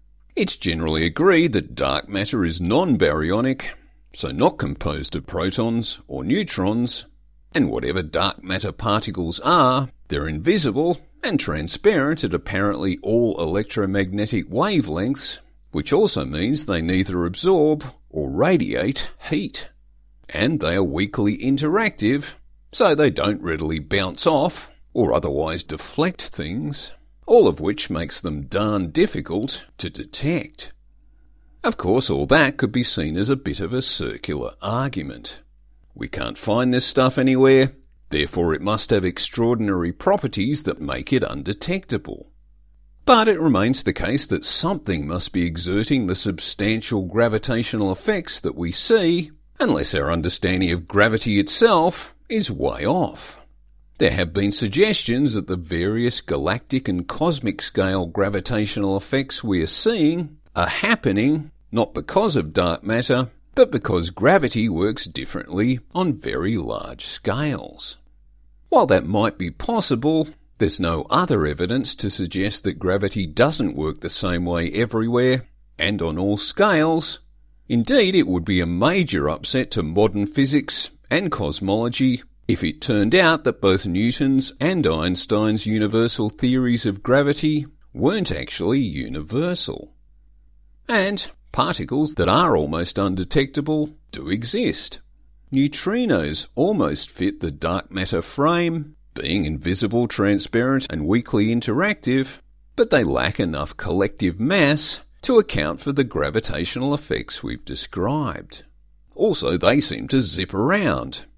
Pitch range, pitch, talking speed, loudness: 90-135 Hz, 105 Hz, 130 wpm, -21 LUFS